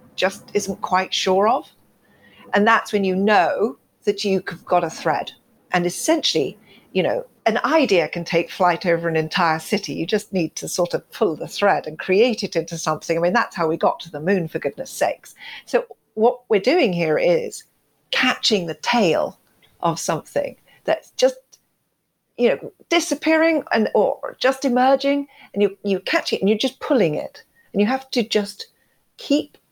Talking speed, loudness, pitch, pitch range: 180 wpm, -20 LUFS, 205 Hz, 175-265 Hz